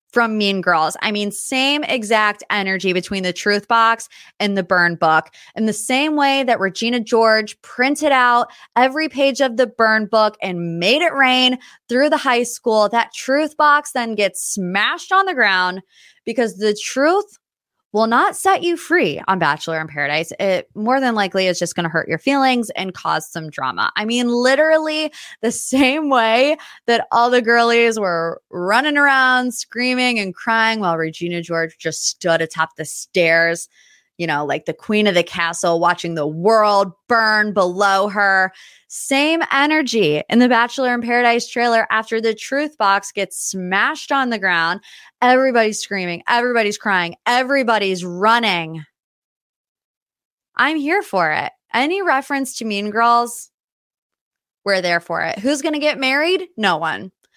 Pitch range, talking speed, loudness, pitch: 185-260 Hz, 165 wpm, -17 LUFS, 225 Hz